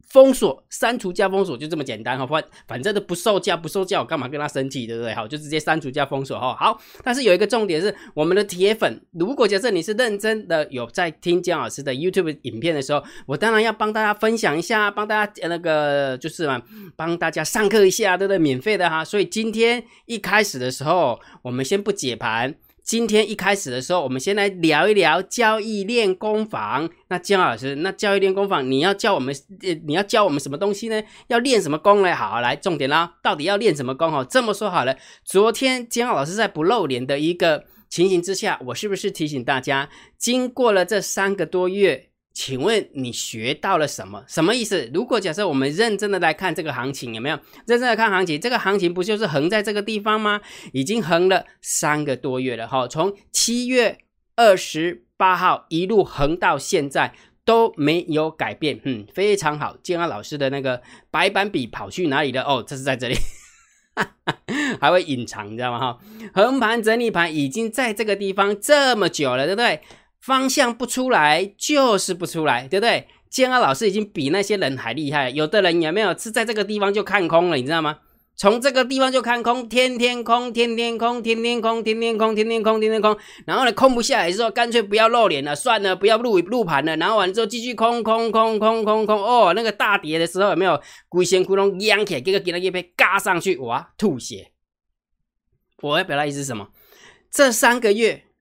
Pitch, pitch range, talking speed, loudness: 195 Hz, 155-220 Hz, 320 characters per minute, -20 LUFS